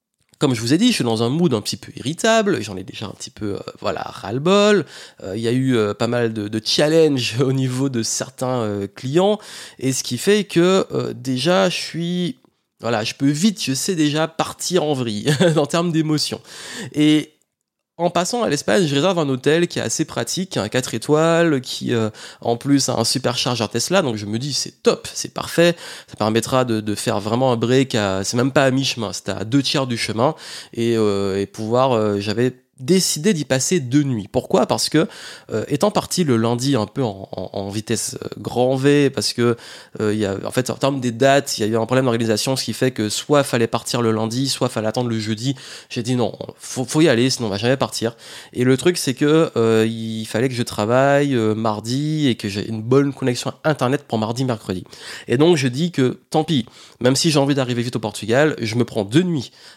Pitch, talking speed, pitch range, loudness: 130 Hz, 235 wpm, 115-150 Hz, -19 LUFS